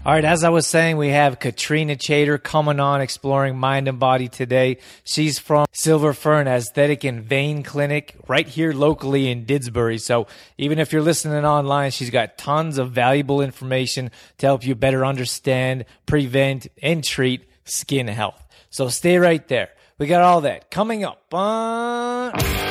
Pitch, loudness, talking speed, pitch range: 140 Hz, -20 LUFS, 165 wpm, 130-155 Hz